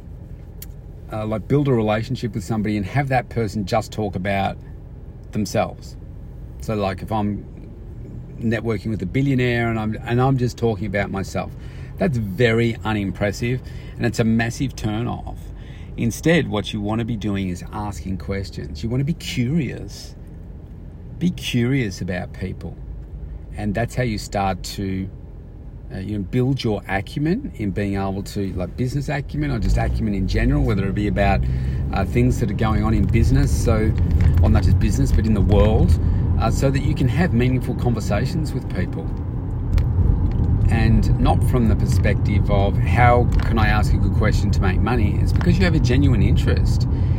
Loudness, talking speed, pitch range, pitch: -21 LUFS, 180 wpm, 95-120 Hz, 105 Hz